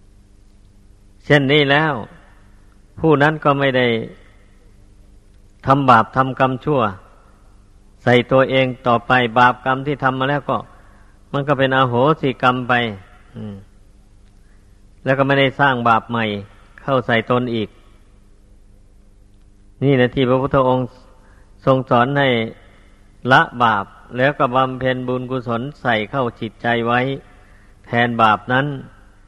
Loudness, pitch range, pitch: -17 LUFS, 100-130 Hz, 115 Hz